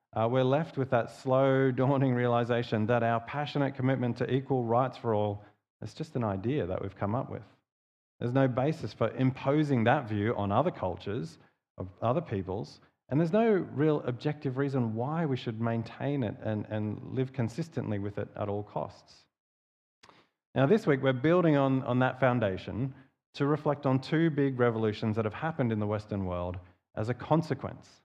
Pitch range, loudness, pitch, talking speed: 110-135 Hz, -30 LUFS, 125 Hz, 180 wpm